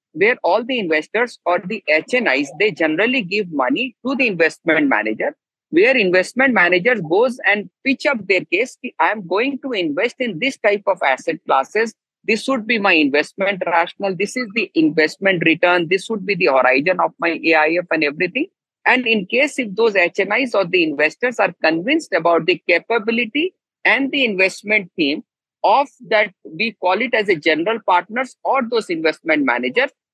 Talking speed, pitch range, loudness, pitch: 175 wpm, 170-250 Hz, -17 LUFS, 205 Hz